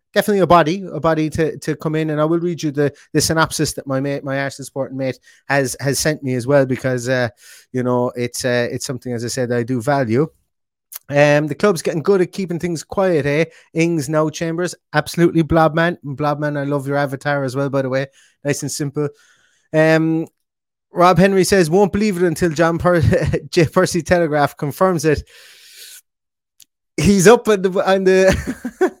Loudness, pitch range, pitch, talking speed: -17 LUFS, 140-175 Hz, 155 Hz, 195 wpm